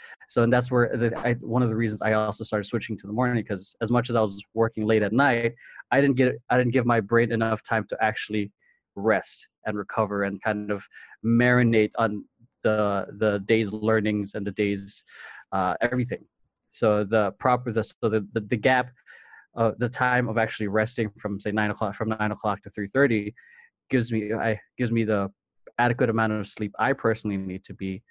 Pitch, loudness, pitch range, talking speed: 110 Hz, -25 LUFS, 105-120 Hz, 205 wpm